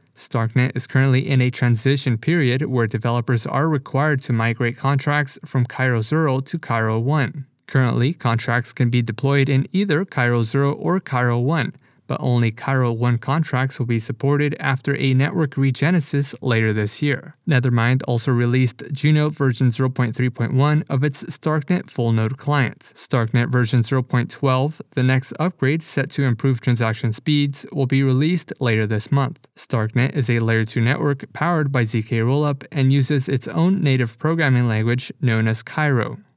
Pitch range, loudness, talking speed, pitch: 120-145 Hz, -20 LUFS, 160 wpm, 130 Hz